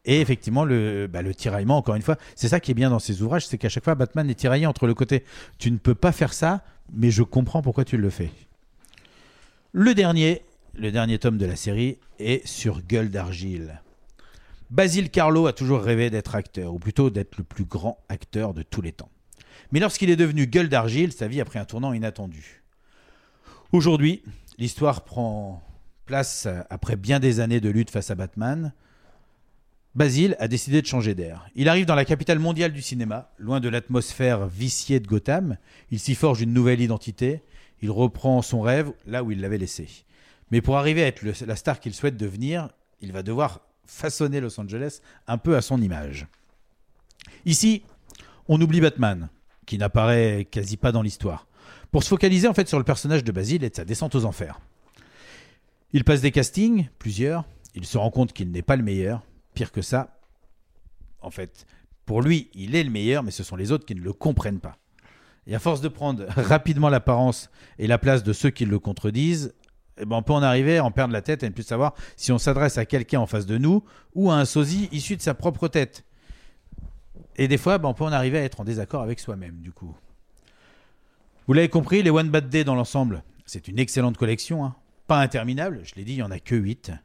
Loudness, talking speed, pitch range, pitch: -23 LUFS, 210 wpm, 105-145 Hz, 125 Hz